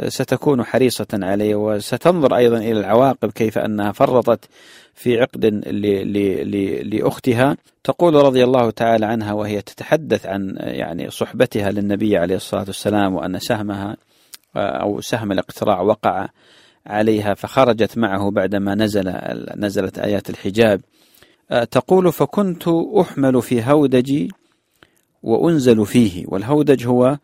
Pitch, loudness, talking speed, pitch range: 110 Hz, -18 LUFS, 115 wpm, 100-130 Hz